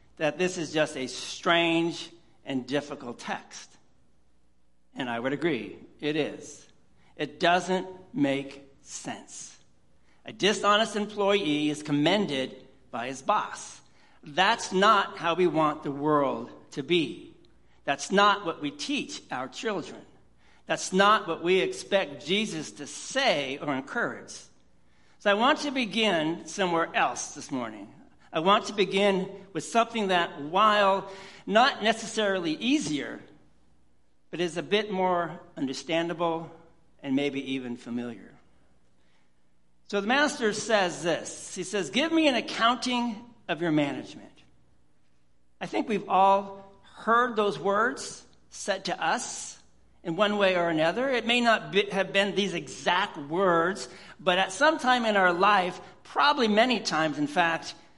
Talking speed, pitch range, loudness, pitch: 140 wpm, 145-205 Hz, -27 LUFS, 175 Hz